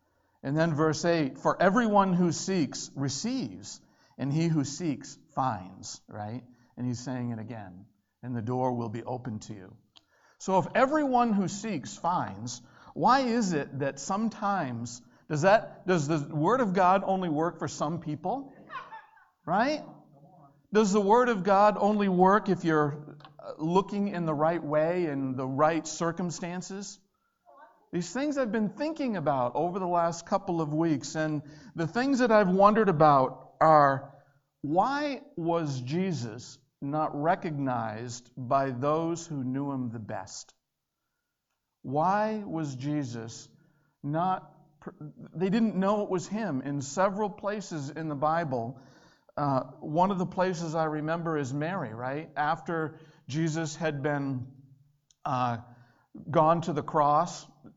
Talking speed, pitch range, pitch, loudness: 140 wpm, 140-190 Hz, 160 Hz, -28 LUFS